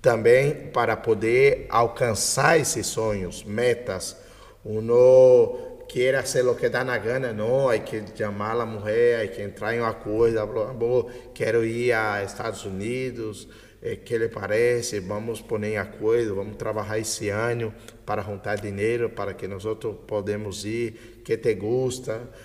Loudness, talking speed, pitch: -24 LUFS, 160 wpm, 115 Hz